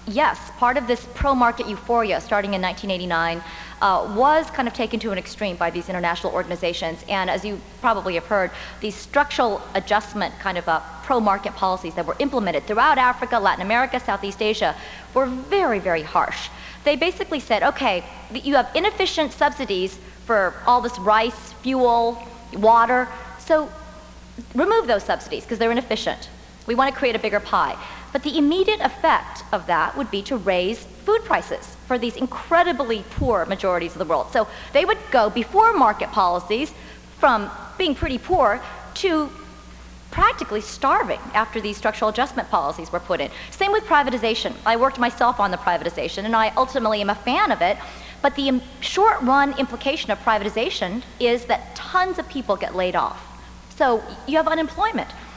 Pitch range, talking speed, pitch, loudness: 200-275 Hz, 165 wpm, 235 Hz, -21 LUFS